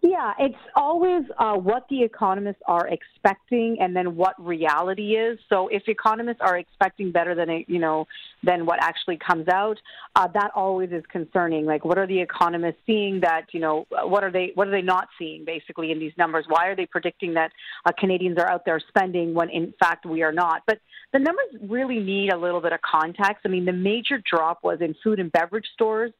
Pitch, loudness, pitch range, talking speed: 185 Hz, -23 LUFS, 170-210 Hz, 210 wpm